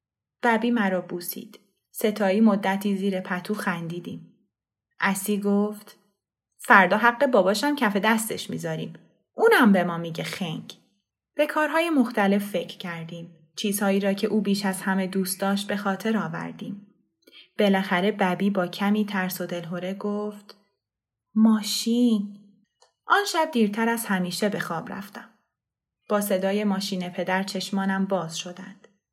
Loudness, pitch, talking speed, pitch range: -24 LUFS, 200 Hz, 130 wpm, 185-215 Hz